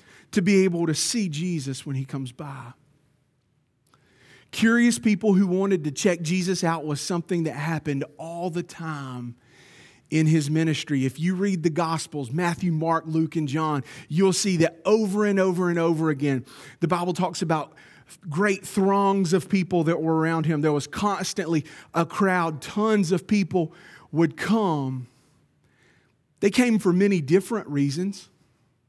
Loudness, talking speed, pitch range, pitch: -24 LUFS, 155 wpm, 150-190 Hz, 165 Hz